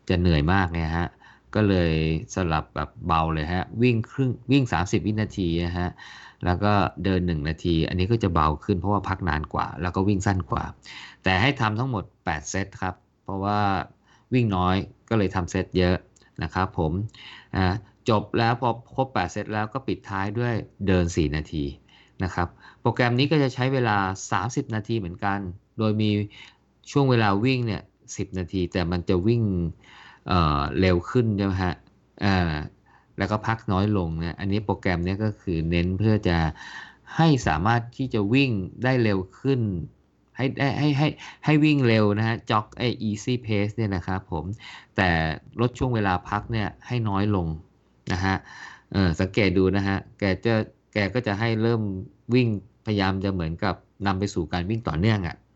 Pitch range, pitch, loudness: 90-115 Hz, 100 Hz, -25 LUFS